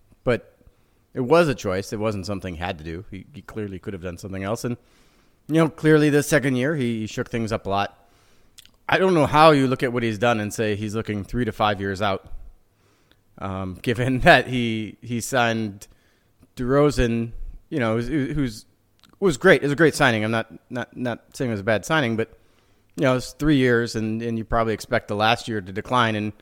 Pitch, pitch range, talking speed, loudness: 115 Hz, 100-130 Hz, 225 wpm, -22 LUFS